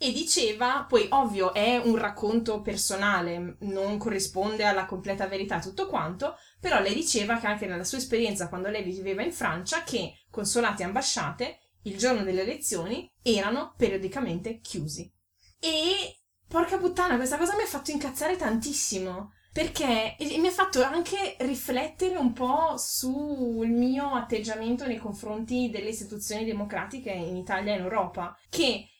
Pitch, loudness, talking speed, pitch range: 225 Hz, -28 LUFS, 150 wpm, 200-280 Hz